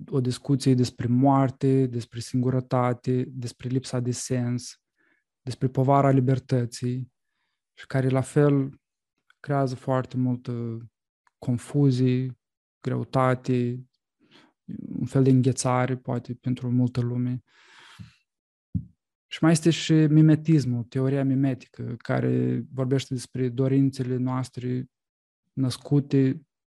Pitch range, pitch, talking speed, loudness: 125-135 Hz, 130 Hz, 95 wpm, -25 LUFS